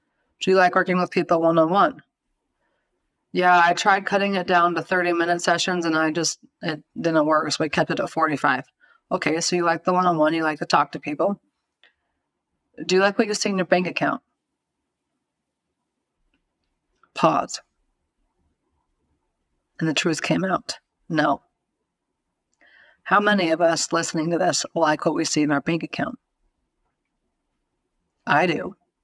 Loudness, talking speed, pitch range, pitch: -21 LUFS, 165 wpm, 160-185 Hz, 170 Hz